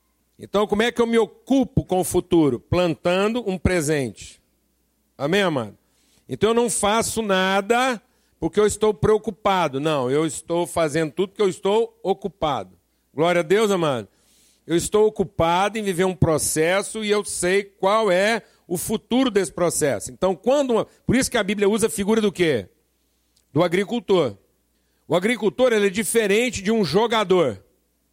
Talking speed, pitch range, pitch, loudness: 160 wpm, 165-220 Hz, 195 Hz, -21 LUFS